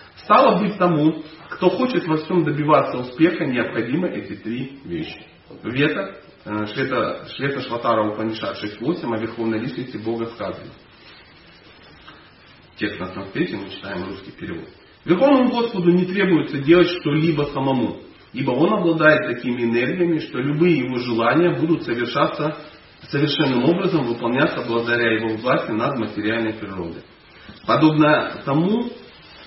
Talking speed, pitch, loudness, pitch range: 120 wpm, 145 Hz, -20 LUFS, 115-165 Hz